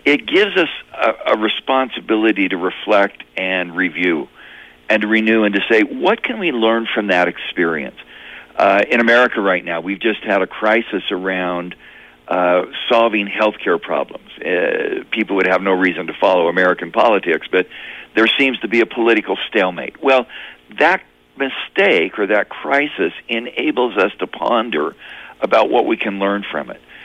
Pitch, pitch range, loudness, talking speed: 110 Hz, 95-115 Hz, -16 LUFS, 165 wpm